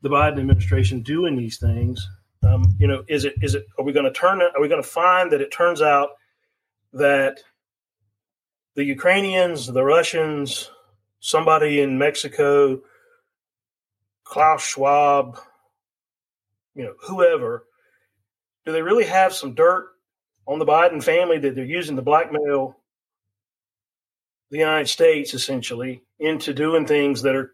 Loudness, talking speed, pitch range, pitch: -19 LUFS, 140 wpm, 110-160 Hz, 140 Hz